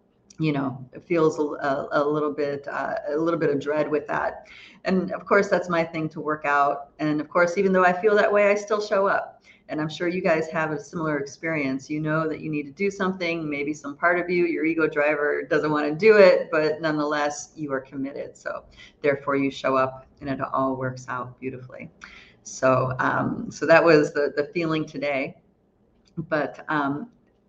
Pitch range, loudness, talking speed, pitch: 145-170 Hz, -24 LUFS, 205 wpm, 150 Hz